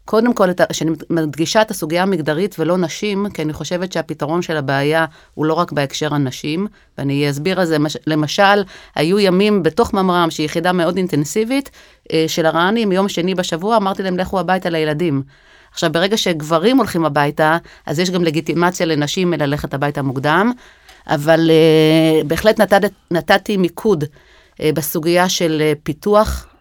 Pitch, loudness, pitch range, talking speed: 170 Hz, -16 LUFS, 155-190 Hz, 145 wpm